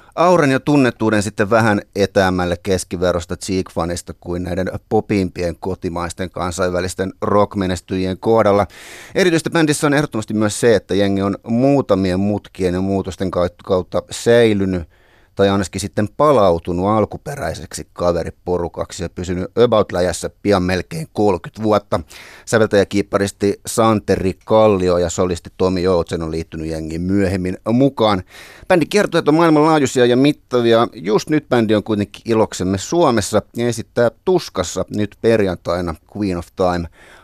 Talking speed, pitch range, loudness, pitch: 125 wpm, 90-115 Hz, -17 LUFS, 100 Hz